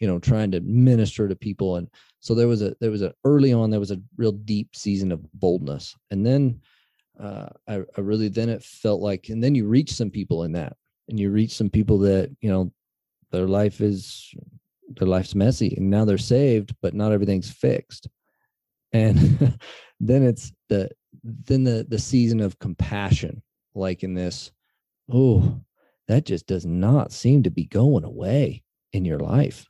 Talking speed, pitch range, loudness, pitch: 185 wpm, 100-120 Hz, -22 LUFS, 110 Hz